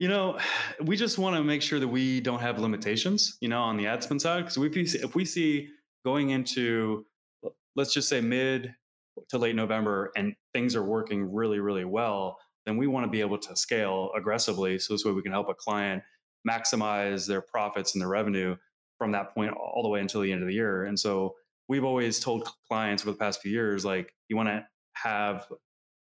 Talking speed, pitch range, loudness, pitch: 215 wpm, 100-135 Hz, -29 LUFS, 110 Hz